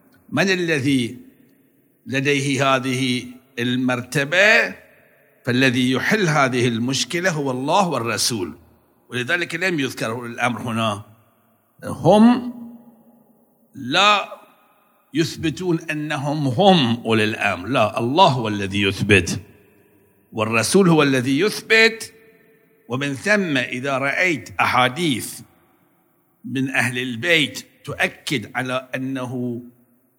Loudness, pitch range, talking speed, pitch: -19 LUFS, 120-175 Hz, 85 wpm, 135 Hz